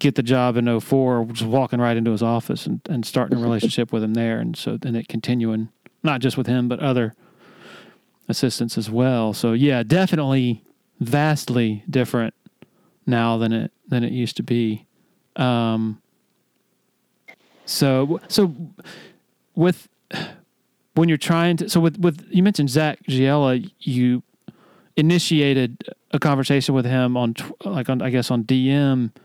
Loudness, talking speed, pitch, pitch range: -21 LUFS, 155 wpm, 130 Hz, 115-150 Hz